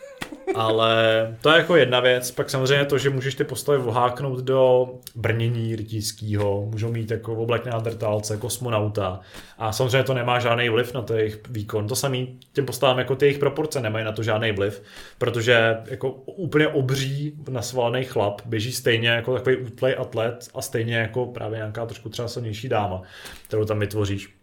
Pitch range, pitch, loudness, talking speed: 110-130 Hz, 120 Hz, -23 LUFS, 170 wpm